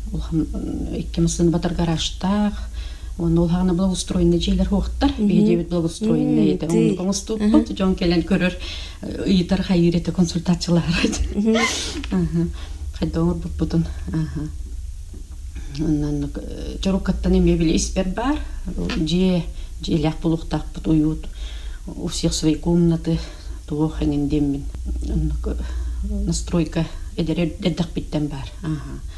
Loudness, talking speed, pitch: -21 LUFS, 100 wpm, 165 Hz